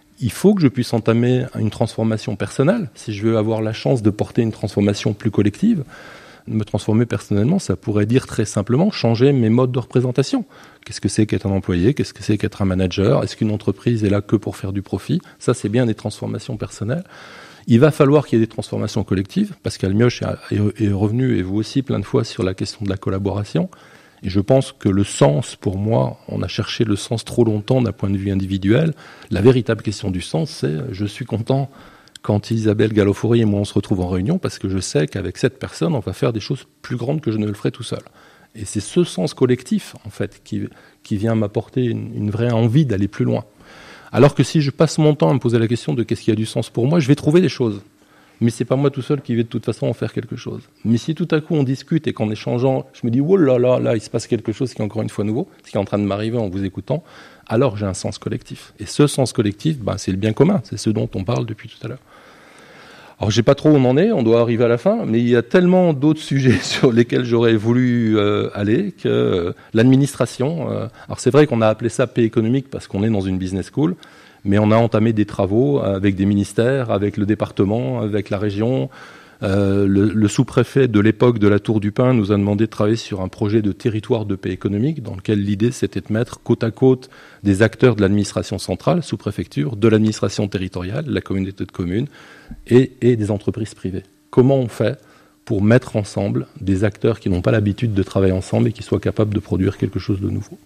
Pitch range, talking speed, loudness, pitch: 105-130 Hz, 245 wpm, -19 LUFS, 115 Hz